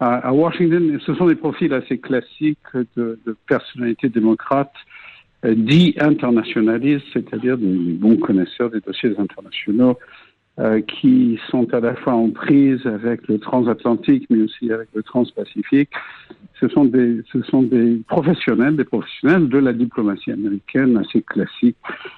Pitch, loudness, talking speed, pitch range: 125 Hz, -18 LUFS, 140 wpm, 115-140 Hz